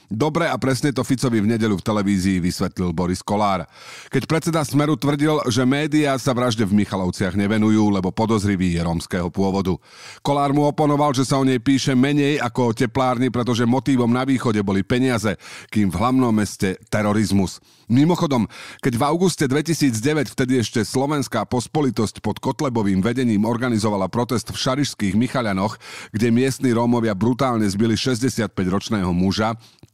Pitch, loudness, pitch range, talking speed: 120 Hz, -20 LUFS, 105-135 Hz, 150 wpm